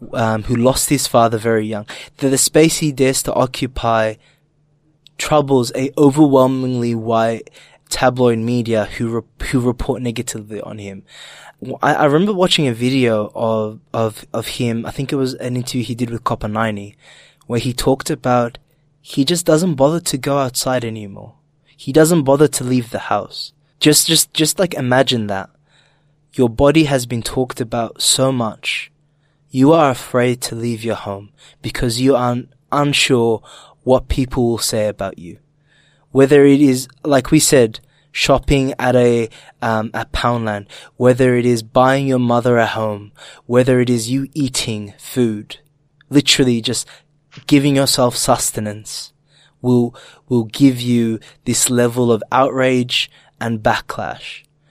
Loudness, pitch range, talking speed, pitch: -16 LUFS, 115-145 Hz, 150 wpm, 130 Hz